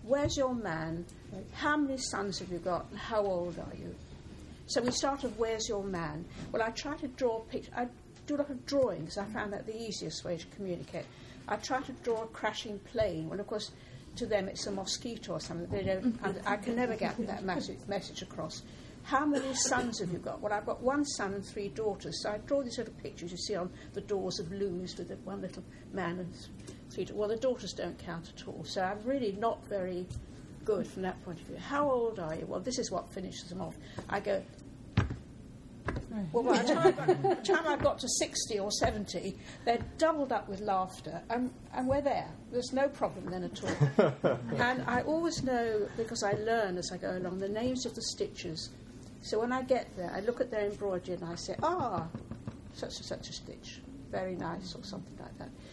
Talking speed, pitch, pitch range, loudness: 215 wpm, 210 Hz, 185-250 Hz, -34 LUFS